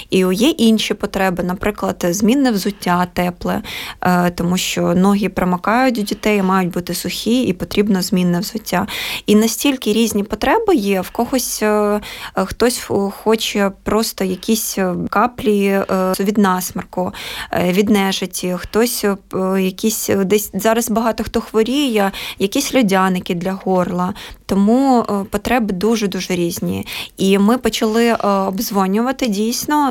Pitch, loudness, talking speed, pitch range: 205 Hz, -17 LUFS, 115 wpm, 185-225 Hz